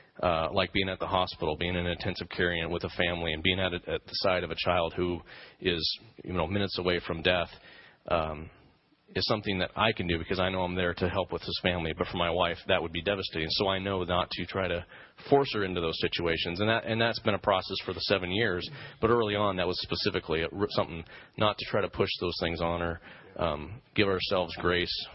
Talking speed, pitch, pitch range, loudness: 240 wpm, 90 Hz, 85-95 Hz, -30 LUFS